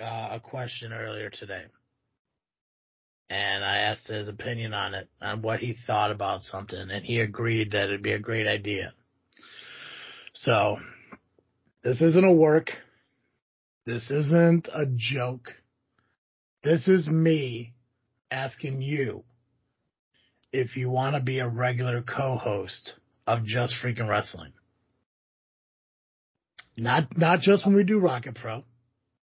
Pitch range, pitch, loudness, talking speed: 110-135 Hz, 120 Hz, -26 LUFS, 125 wpm